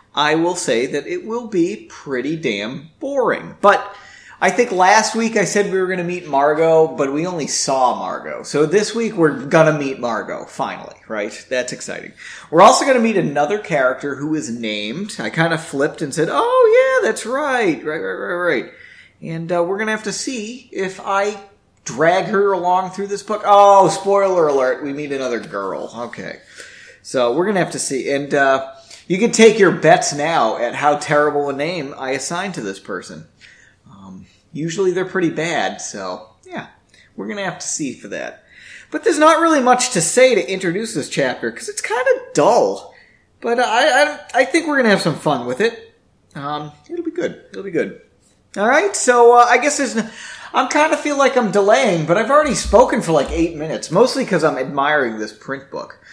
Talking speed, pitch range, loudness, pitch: 205 wpm, 150-240 Hz, -17 LUFS, 190 Hz